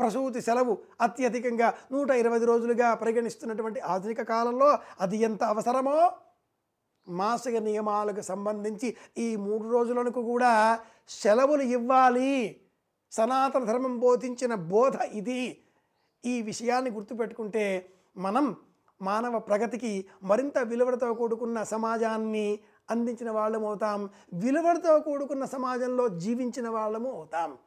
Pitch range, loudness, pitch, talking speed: 215-250 Hz, -28 LUFS, 235 Hz, 100 wpm